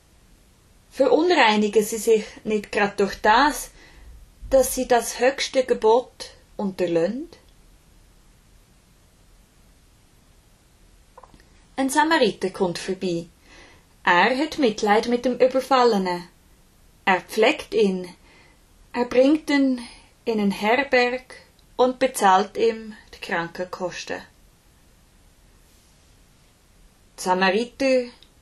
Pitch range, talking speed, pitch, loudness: 180-255 Hz, 80 wpm, 220 Hz, -21 LUFS